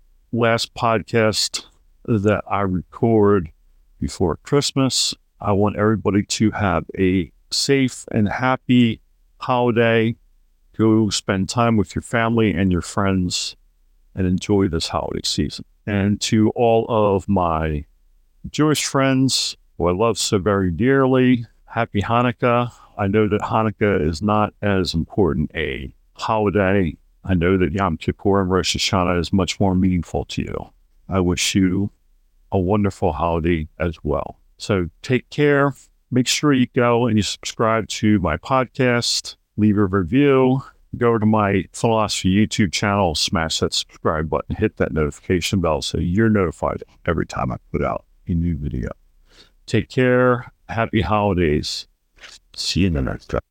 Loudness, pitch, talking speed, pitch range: -20 LUFS, 100 Hz, 145 wpm, 90-115 Hz